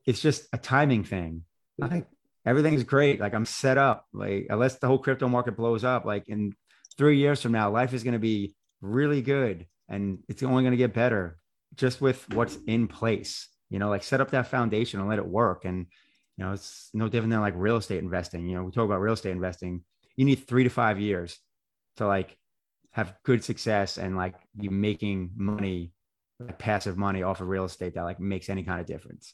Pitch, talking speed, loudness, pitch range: 105 Hz, 215 wpm, -27 LUFS, 95-125 Hz